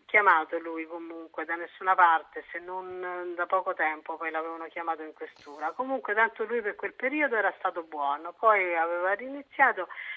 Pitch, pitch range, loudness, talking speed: 170 Hz, 160-190 Hz, -28 LUFS, 165 wpm